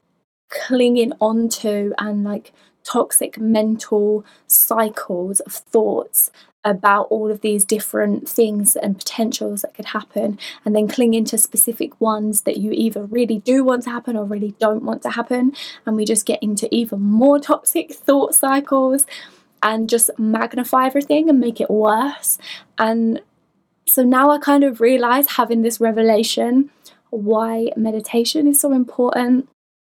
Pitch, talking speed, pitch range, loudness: 230 Hz, 145 wpm, 215-255 Hz, -17 LUFS